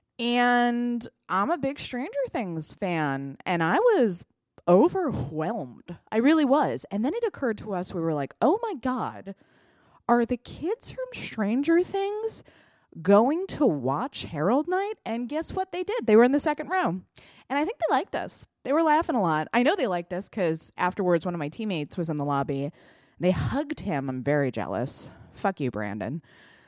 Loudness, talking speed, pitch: -26 LUFS, 185 wpm, 220 Hz